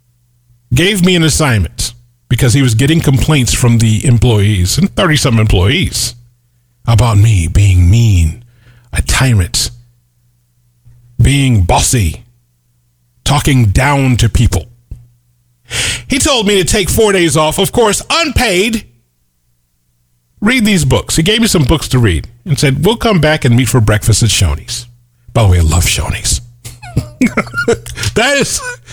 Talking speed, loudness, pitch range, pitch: 140 wpm, -11 LUFS, 110-145 Hz, 120 Hz